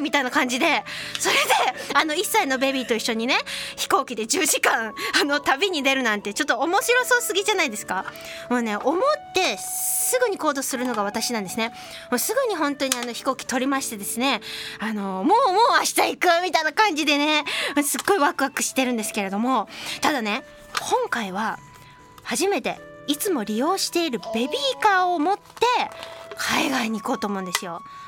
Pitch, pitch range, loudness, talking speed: 285 Hz, 245-370 Hz, -22 LUFS, 370 characters per minute